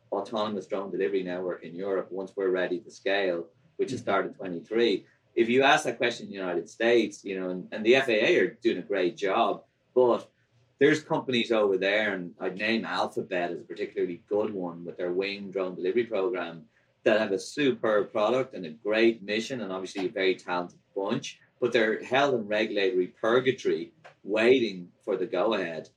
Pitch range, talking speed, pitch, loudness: 95-125 Hz, 185 wpm, 105 Hz, -28 LUFS